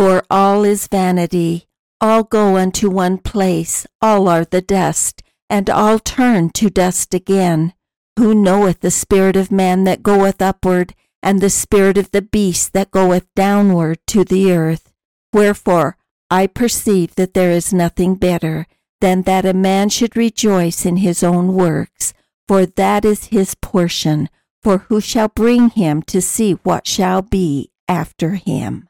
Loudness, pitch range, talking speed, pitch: -15 LUFS, 180-205 Hz, 155 wpm, 190 Hz